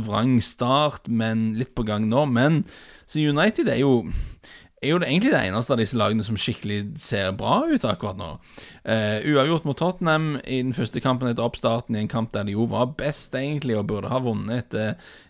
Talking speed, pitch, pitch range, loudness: 210 wpm, 120 Hz, 110-135 Hz, -23 LUFS